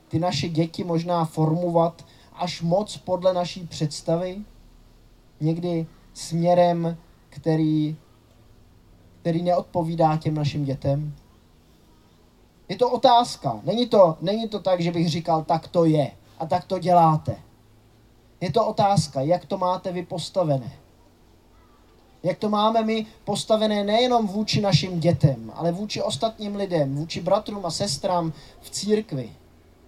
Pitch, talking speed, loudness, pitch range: 165 Hz, 125 wpm, -23 LUFS, 135-185 Hz